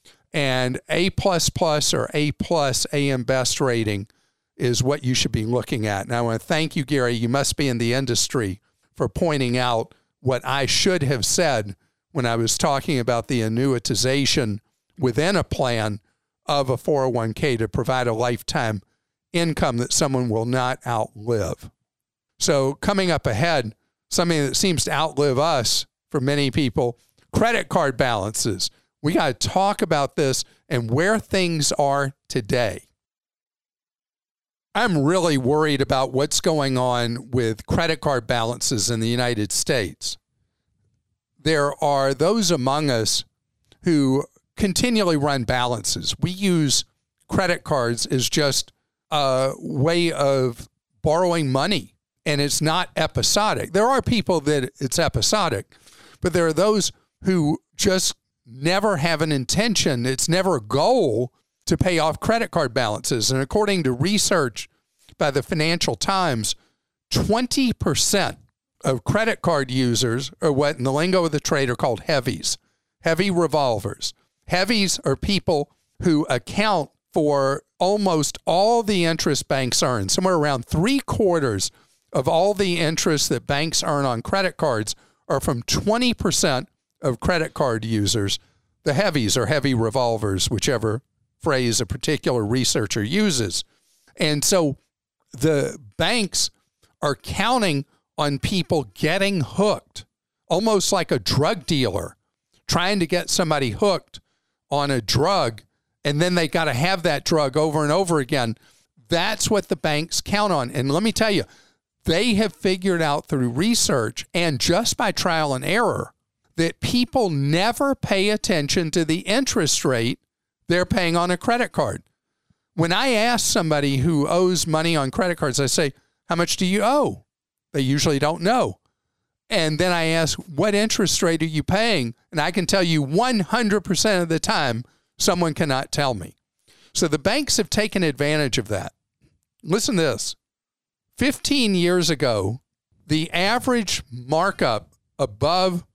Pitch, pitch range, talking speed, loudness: 150 Hz, 125-180 Hz, 145 wpm, -21 LUFS